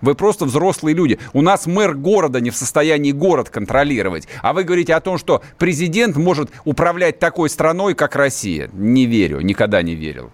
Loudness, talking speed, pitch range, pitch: -16 LUFS, 180 wpm, 130-180 Hz, 155 Hz